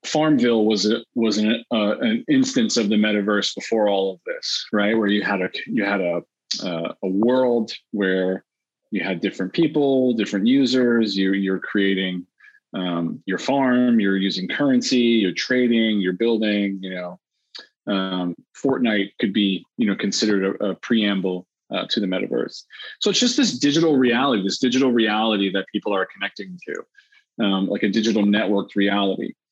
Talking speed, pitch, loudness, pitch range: 165 wpm, 105 Hz, -21 LUFS, 95-125 Hz